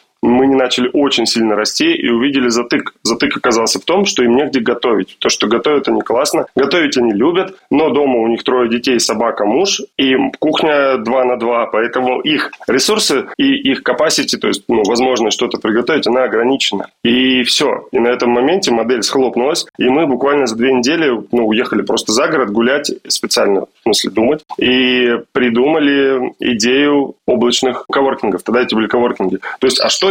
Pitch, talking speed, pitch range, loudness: 125 Hz, 175 wpm, 120-140 Hz, -13 LUFS